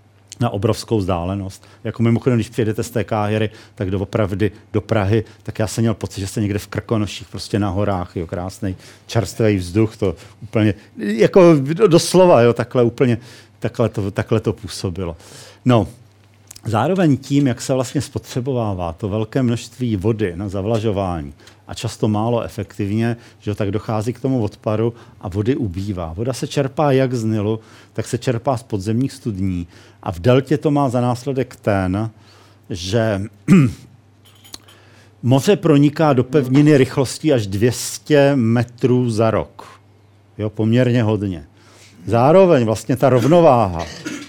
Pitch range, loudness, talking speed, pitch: 105-125 Hz, -18 LUFS, 145 wpm, 110 Hz